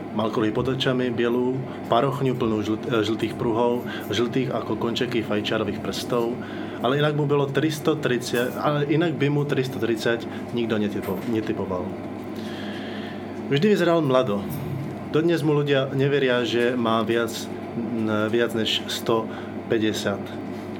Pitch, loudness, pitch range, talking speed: 120 Hz, -24 LUFS, 115-135 Hz, 115 wpm